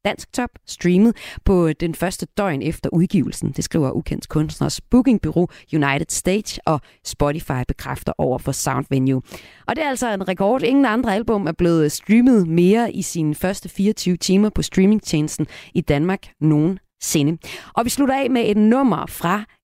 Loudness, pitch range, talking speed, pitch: -19 LUFS, 155-210 Hz, 160 wpm, 180 Hz